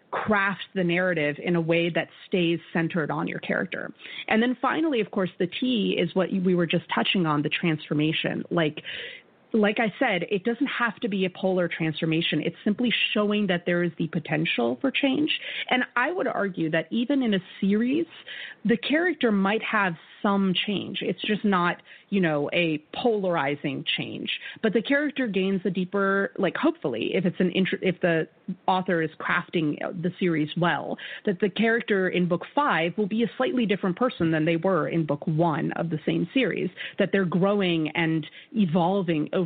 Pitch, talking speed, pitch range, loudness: 185 Hz, 185 wpm, 170-215 Hz, -25 LUFS